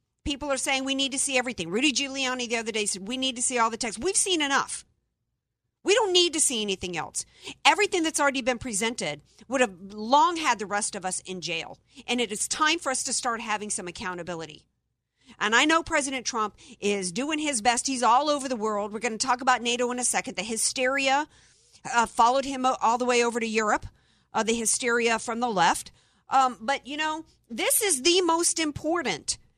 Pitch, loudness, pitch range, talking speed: 250 Hz, -25 LUFS, 220-280 Hz, 215 wpm